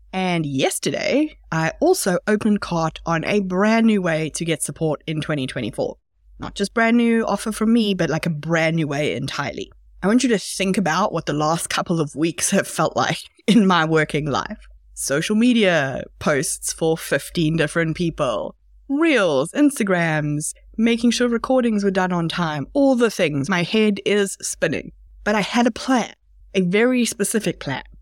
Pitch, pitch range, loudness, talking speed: 190 Hz, 160-225 Hz, -20 LUFS, 175 wpm